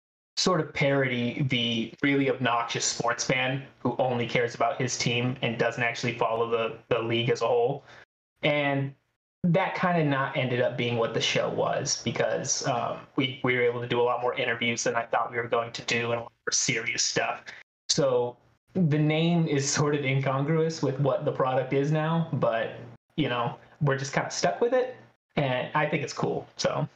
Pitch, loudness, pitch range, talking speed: 130 Hz, -27 LUFS, 120-145 Hz, 205 wpm